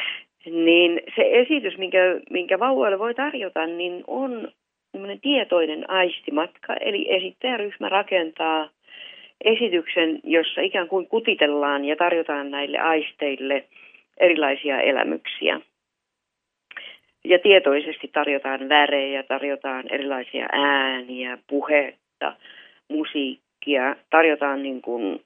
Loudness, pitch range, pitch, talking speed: -22 LUFS, 140-190 Hz, 160 Hz, 90 wpm